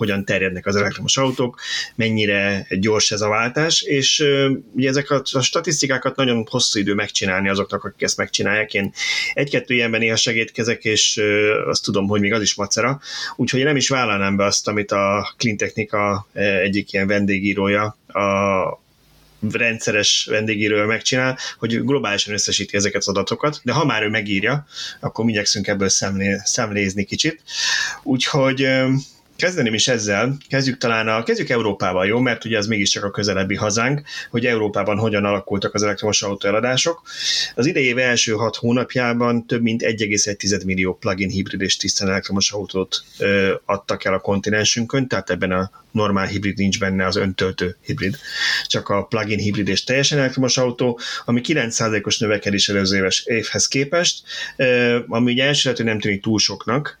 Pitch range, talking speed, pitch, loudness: 100-125 Hz, 155 wpm, 110 Hz, -19 LUFS